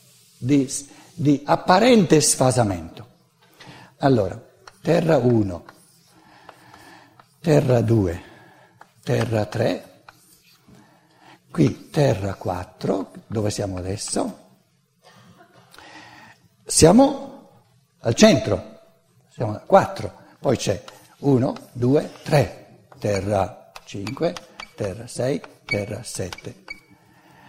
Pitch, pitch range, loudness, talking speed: 125 Hz, 100-155 Hz, -21 LUFS, 75 wpm